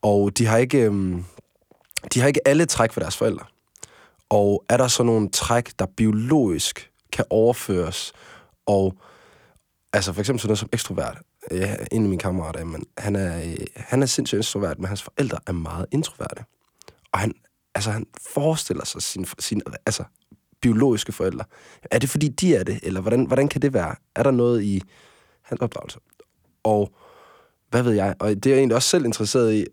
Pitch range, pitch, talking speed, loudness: 100-125 Hz, 110 Hz, 180 wpm, -22 LUFS